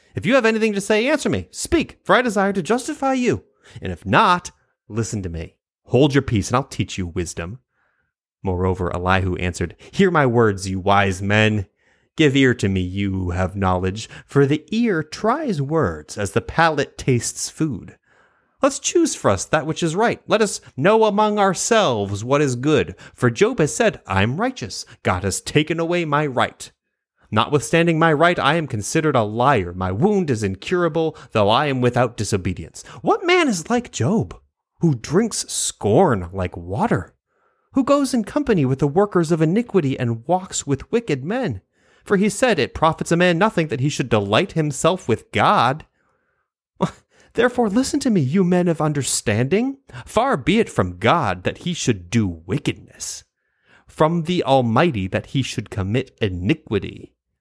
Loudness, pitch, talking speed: -20 LUFS, 150 Hz, 175 wpm